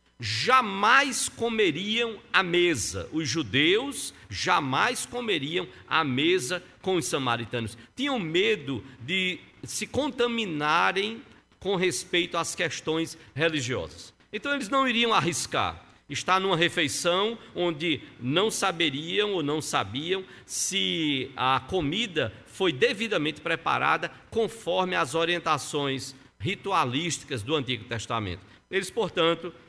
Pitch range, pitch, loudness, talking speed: 145-210 Hz, 175 Hz, -26 LUFS, 105 wpm